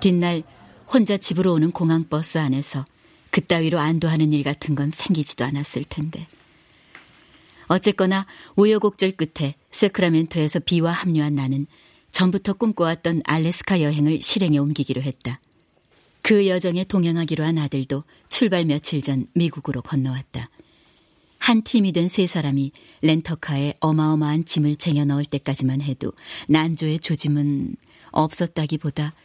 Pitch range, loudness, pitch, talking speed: 145-175 Hz, -21 LUFS, 155 Hz, 310 characters per minute